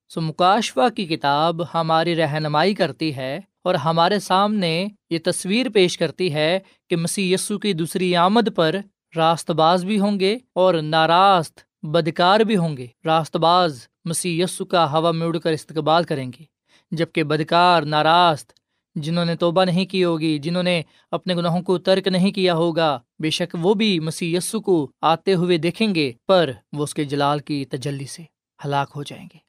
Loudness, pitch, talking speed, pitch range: -20 LUFS, 170 Hz, 175 wpm, 160-185 Hz